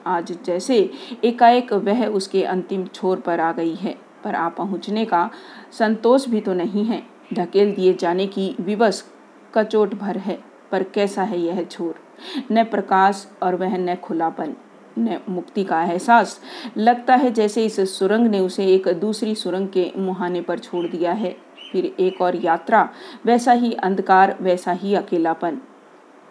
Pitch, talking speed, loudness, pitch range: 195 Hz, 155 wpm, -20 LUFS, 180-220 Hz